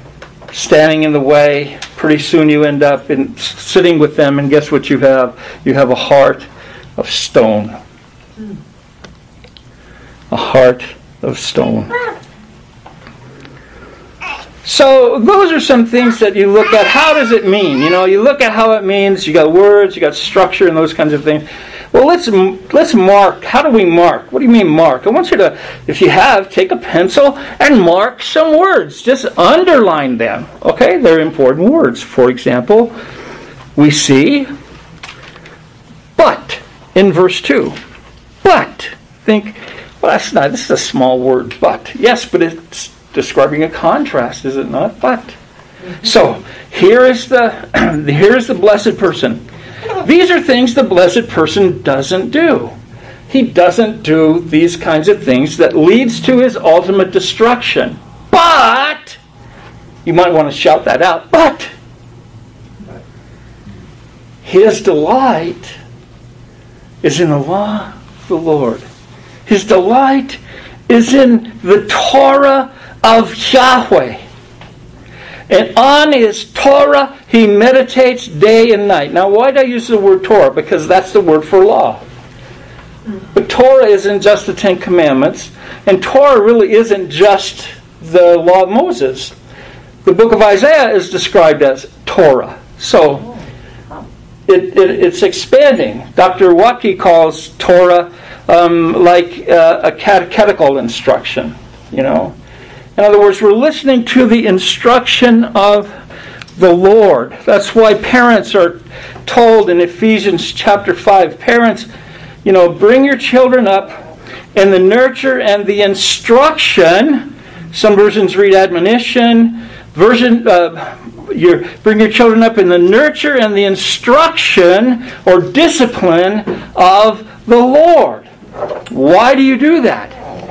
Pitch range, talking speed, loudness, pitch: 170-250 Hz, 140 wpm, -9 LUFS, 200 Hz